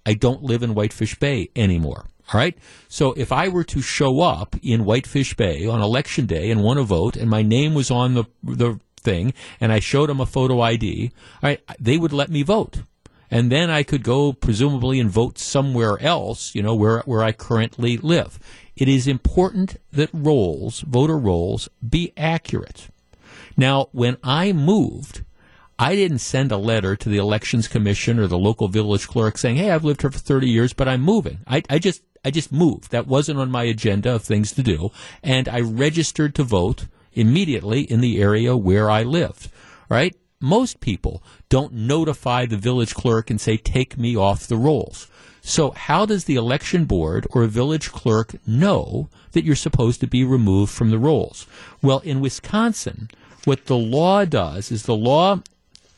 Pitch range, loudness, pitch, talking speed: 110-145 Hz, -20 LUFS, 125 Hz, 190 wpm